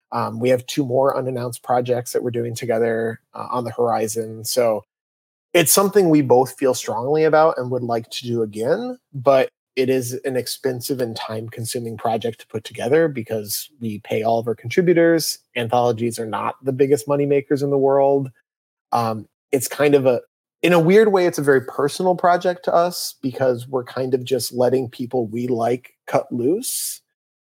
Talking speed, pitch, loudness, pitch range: 185 wpm, 130 Hz, -20 LUFS, 120-145 Hz